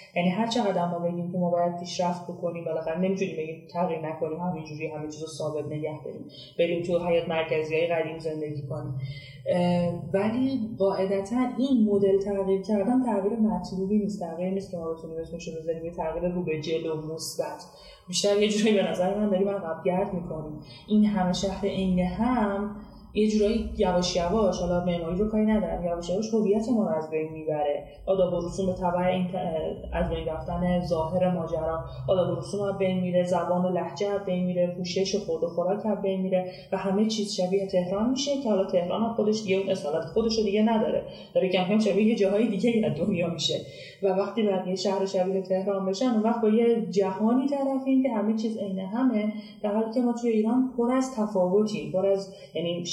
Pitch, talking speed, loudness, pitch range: 185 Hz, 180 wpm, -27 LUFS, 170-210 Hz